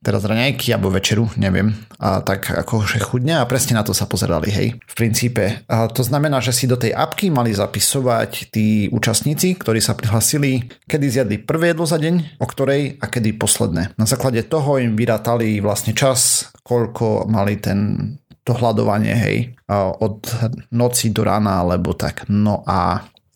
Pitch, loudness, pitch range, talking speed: 115 Hz, -18 LUFS, 105-130 Hz, 170 wpm